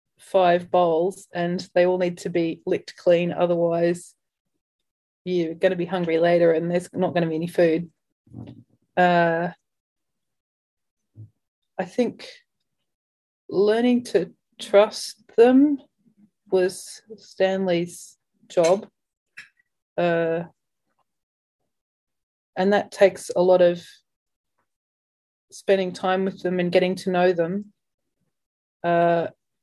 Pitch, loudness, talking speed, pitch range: 180 Hz, -22 LUFS, 105 wpm, 170-195 Hz